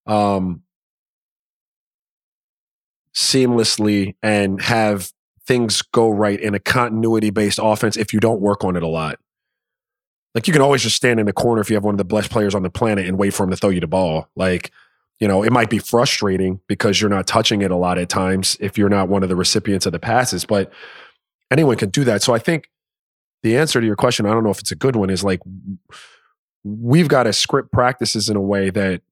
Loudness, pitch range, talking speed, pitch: -17 LUFS, 95-110 Hz, 220 wpm, 105 Hz